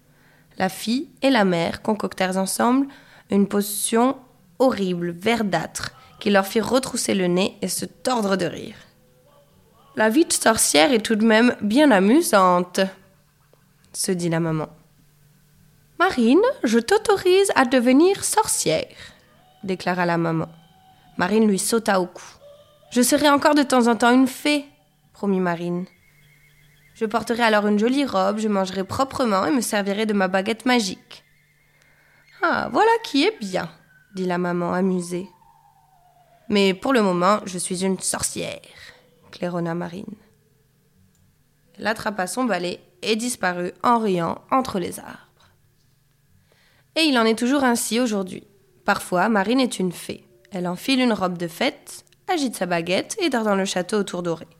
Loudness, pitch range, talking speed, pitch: -21 LUFS, 175-240 Hz, 150 wpm, 195 Hz